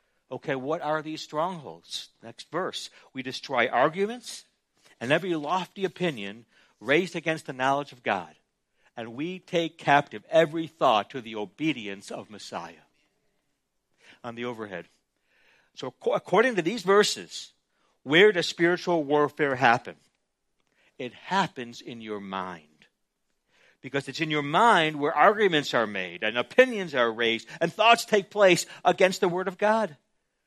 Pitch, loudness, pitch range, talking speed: 155 Hz, -25 LUFS, 125-185 Hz, 140 wpm